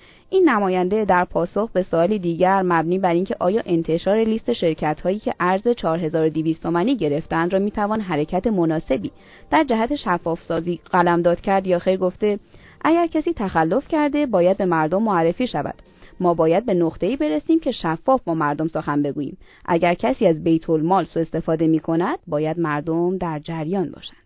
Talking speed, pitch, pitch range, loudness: 165 wpm, 175 Hz, 160-200 Hz, -20 LUFS